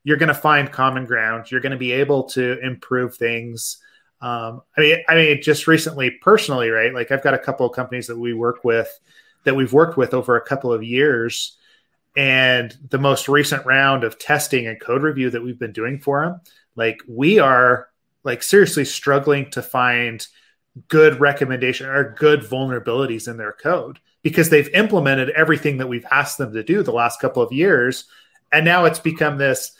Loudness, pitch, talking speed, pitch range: -18 LUFS, 135 Hz, 190 wpm, 120-150 Hz